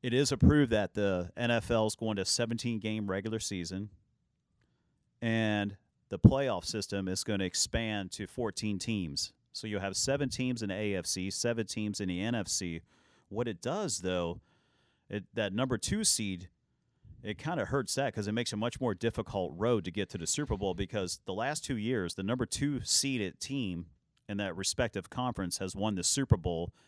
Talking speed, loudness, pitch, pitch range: 190 wpm, -32 LUFS, 105 Hz, 95-120 Hz